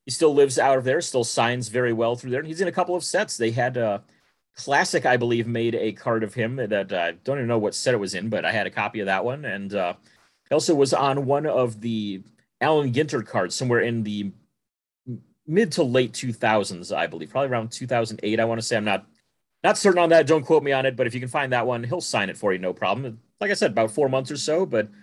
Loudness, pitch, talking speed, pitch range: -23 LUFS, 125 Hz, 265 wpm, 115-140 Hz